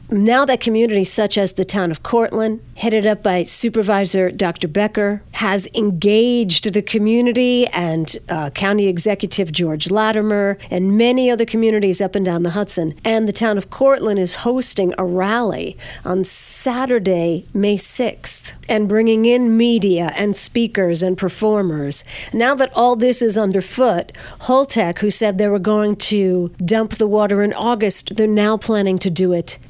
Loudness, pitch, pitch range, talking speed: -15 LUFS, 210 Hz, 185-225 Hz, 160 wpm